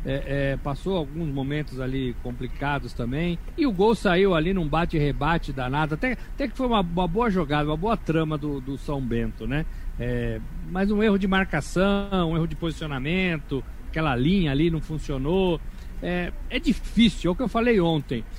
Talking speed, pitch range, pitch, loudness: 185 wpm, 140-190 Hz, 160 Hz, -25 LUFS